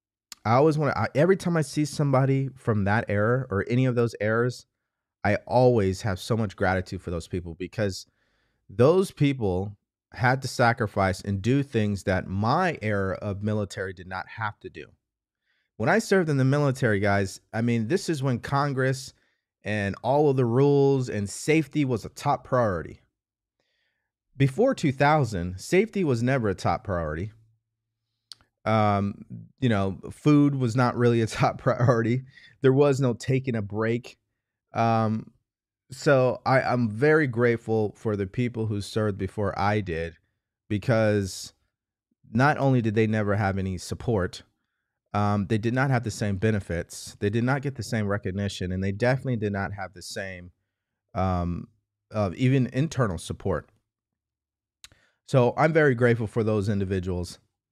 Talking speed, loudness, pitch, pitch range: 155 wpm, -25 LUFS, 110 Hz, 100-130 Hz